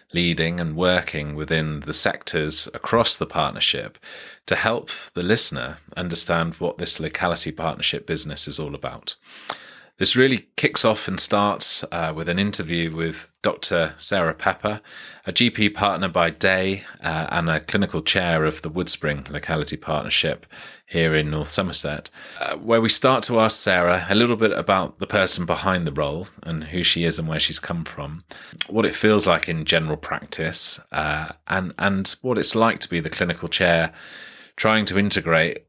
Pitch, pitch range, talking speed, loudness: 85 Hz, 80-100 Hz, 170 wpm, -20 LUFS